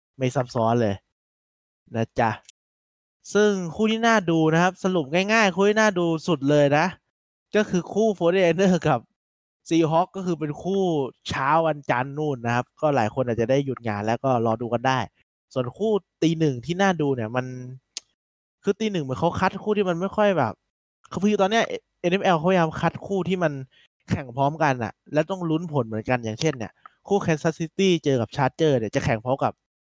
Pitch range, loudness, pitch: 125-185 Hz, -23 LUFS, 155 Hz